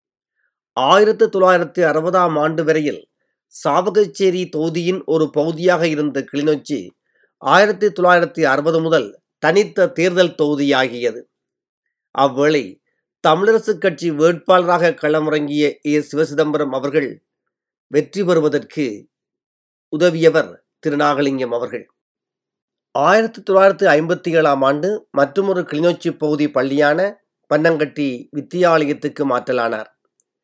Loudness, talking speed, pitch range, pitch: -16 LUFS, 85 wpm, 145-180 Hz, 160 Hz